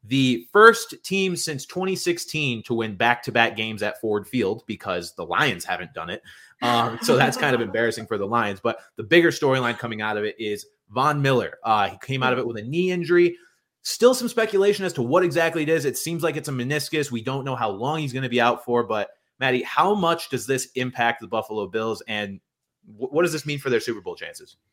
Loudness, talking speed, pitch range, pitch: -23 LUFS, 235 wpm, 115-170 Hz, 130 Hz